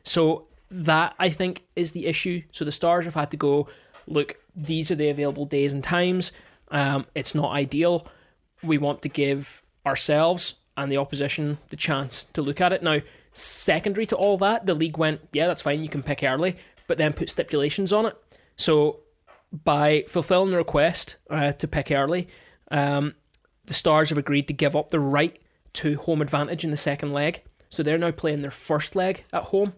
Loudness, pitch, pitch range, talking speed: -24 LUFS, 155 Hz, 145-175 Hz, 195 wpm